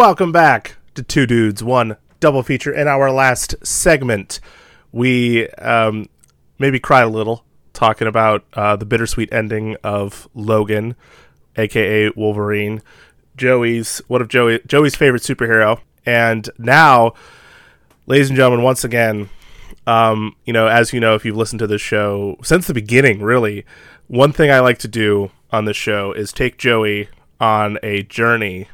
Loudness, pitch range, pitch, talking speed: -15 LUFS, 105-125 Hz, 115 Hz, 150 wpm